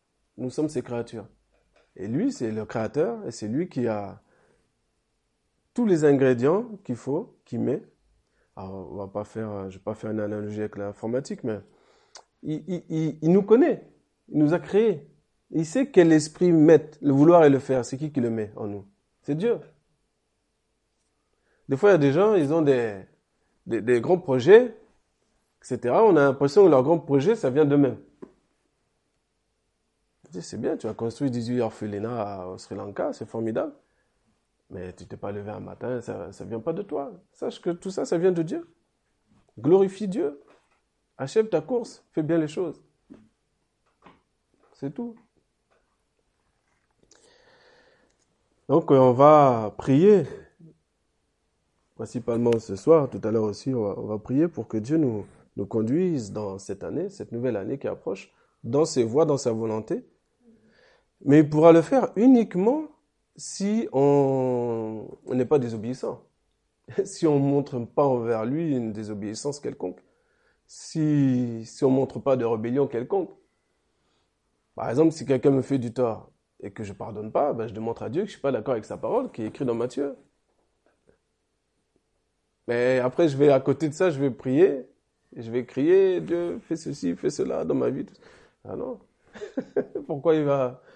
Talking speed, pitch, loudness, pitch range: 170 wpm, 135 Hz, -24 LUFS, 115-165 Hz